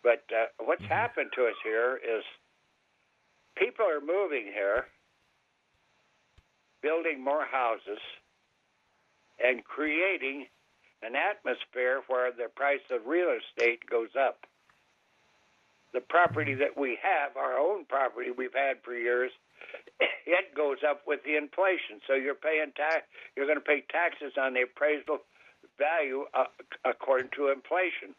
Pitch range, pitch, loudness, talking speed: 135-190 Hz, 150 Hz, -30 LUFS, 130 wpm